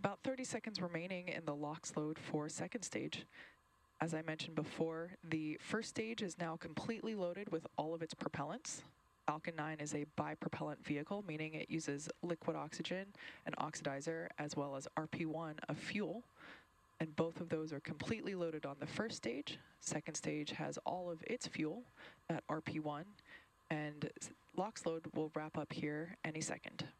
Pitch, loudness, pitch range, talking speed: 160 Hz, -44 LUFS, 155-175 Hz, 165 wpm